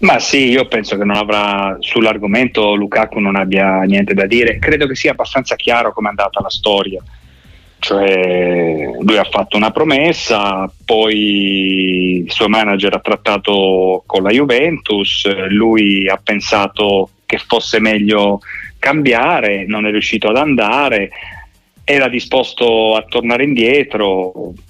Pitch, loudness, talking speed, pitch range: 100 Hz, -13 LUFS, 135 wpm, 95-110 Hz